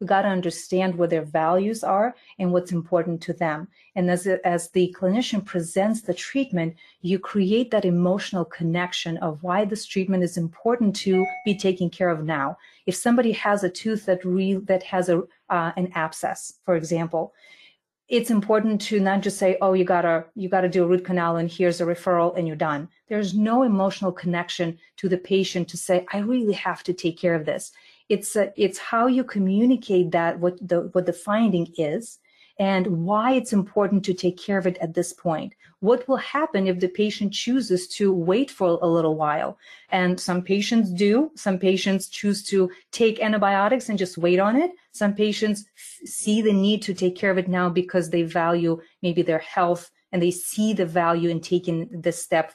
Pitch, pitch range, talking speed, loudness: 185 Hz, 175-205 Hz, 200 wpm, -23 LUFS